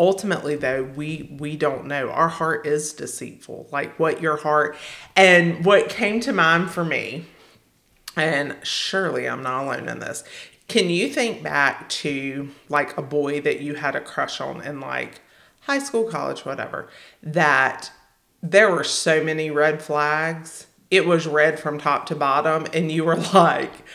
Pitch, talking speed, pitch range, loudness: 155 Hz, 165 wpm, 150-175 Hz, -21 LUFS